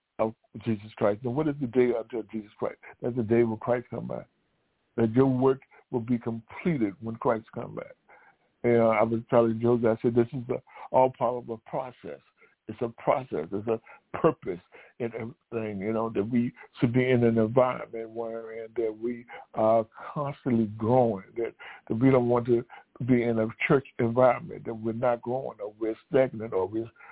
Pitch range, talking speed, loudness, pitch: 115-125 Hz, 195 wpm, -28 LUFS, 120 Hz